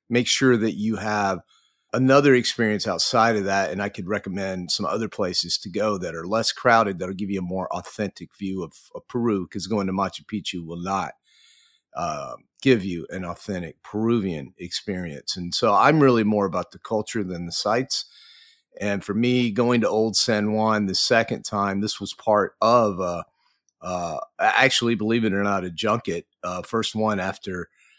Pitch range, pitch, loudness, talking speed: 95-115 Hz, 105 Hz, -23 LUFS, 185 wpm